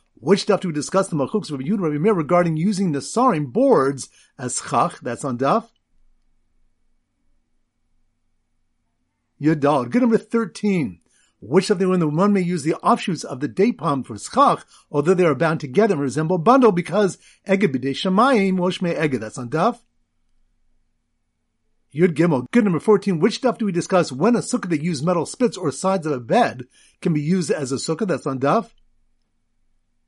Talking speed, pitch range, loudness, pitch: 165 wpm, 135-200 Hz, -20 LUFS, 170 Hz